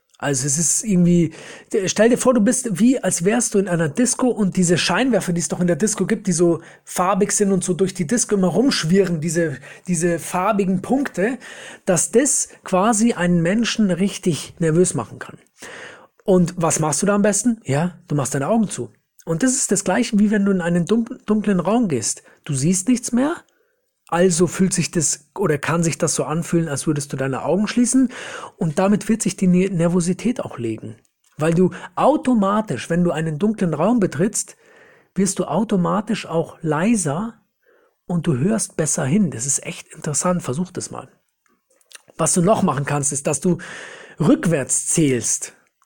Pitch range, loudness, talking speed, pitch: 165-220 Hz, -19 LUFS, 185 wpm, 185 Hz